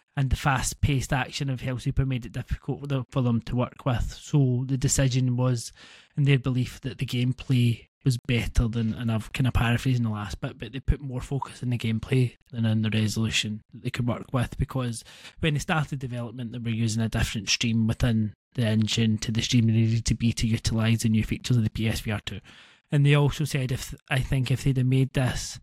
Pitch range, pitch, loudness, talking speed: 115-135 Hz, 125 Hz, -26 LUFS, 225 wpm